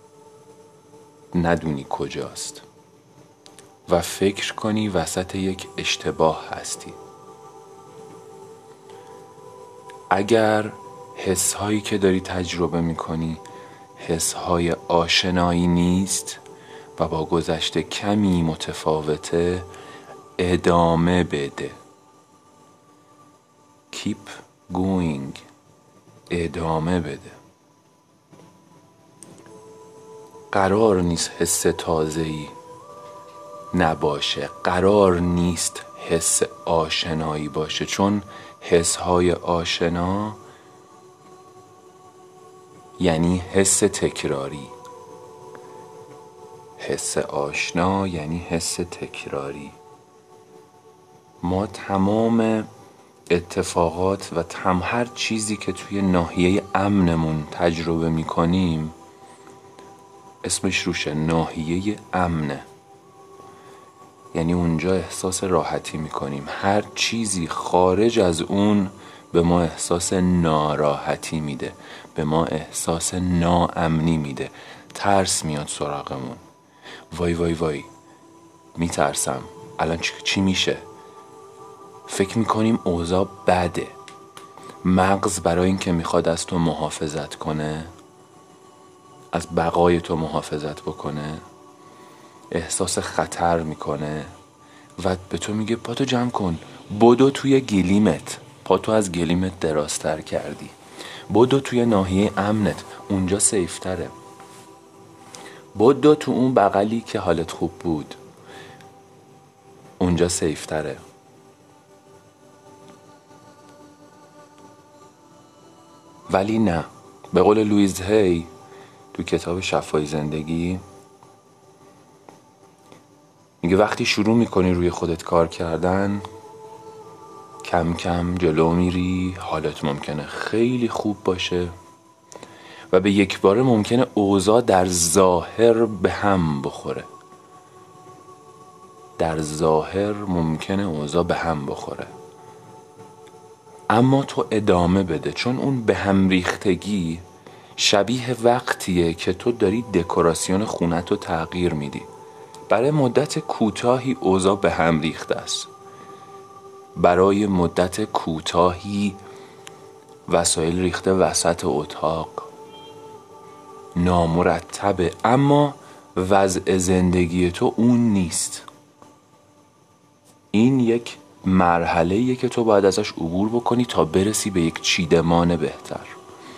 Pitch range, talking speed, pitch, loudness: 85-115 Hz, 85 wpm, 95 Hz, -21 LUFS